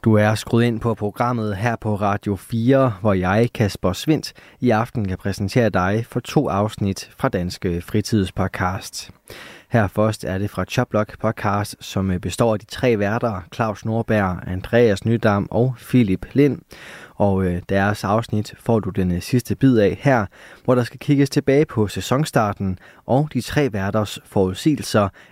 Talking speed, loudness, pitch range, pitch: 160 wpm, -20 LUFS, 100-120 Hz, 110 Hz